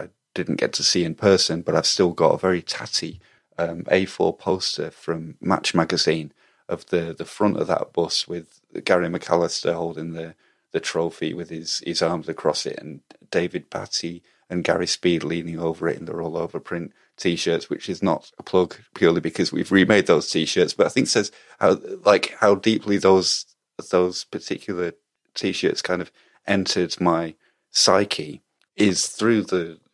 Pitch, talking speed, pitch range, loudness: 85 Hz, 175 wpm, 80-95 Hz, -22 LUFS